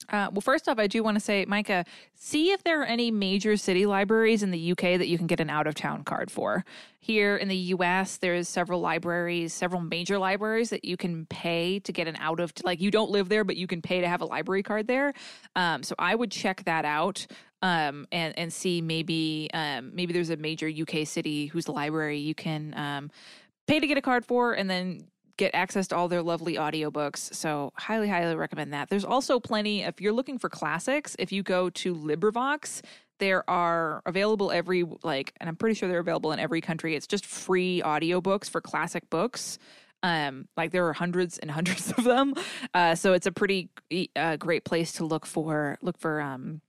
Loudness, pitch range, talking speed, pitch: -28 LUFS, 165-205 Hz, 210 wpm, 180 Hz